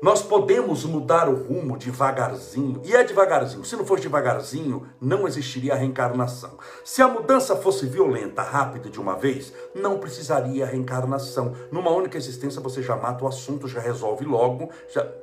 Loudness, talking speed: -23 LUFS, 160 wpm